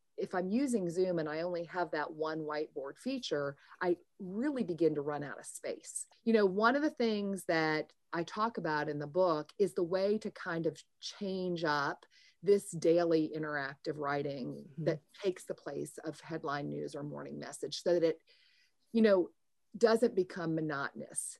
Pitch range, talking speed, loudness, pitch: 155-205 Hz, 175 wpm, -35 LUFS, 175 Hz